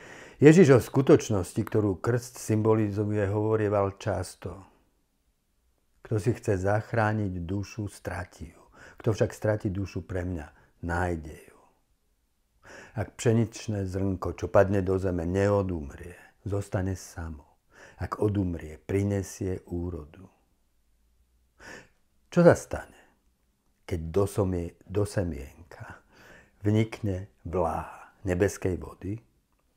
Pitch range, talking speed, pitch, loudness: 80-105 Hz, 95 wpm, 95 Hz, -27 LUFS